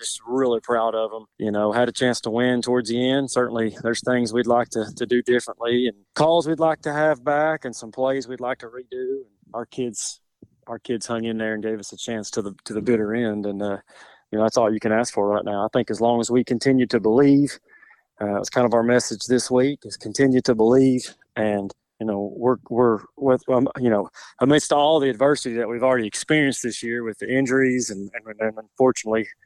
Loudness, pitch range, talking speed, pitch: -22 LUFS, 110-130 Hz, 235 wpm, 120 Hz